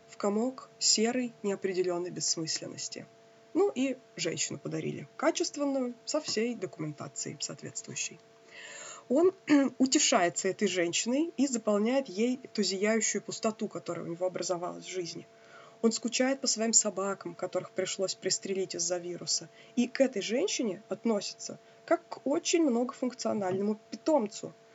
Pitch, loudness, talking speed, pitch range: 220 Hz, -31 LUFS, 120 wpm, 185-260 Hz